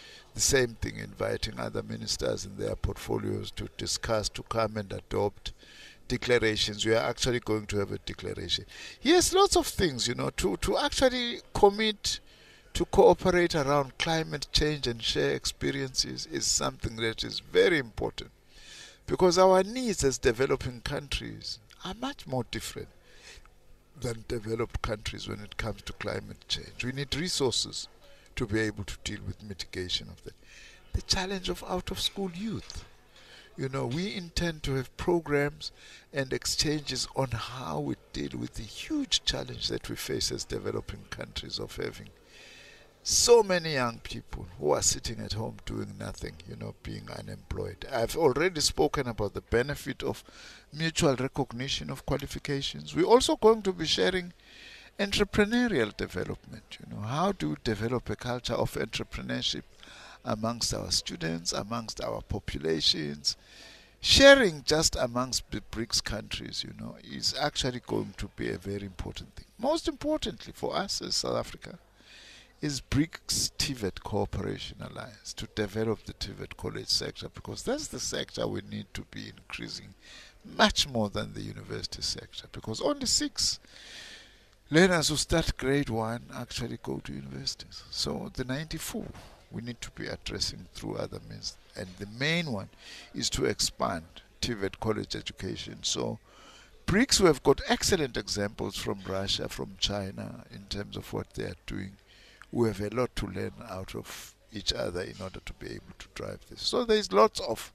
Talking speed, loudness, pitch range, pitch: 160 wpm, -29 LUFS, 100-150 Hz, 115 Hz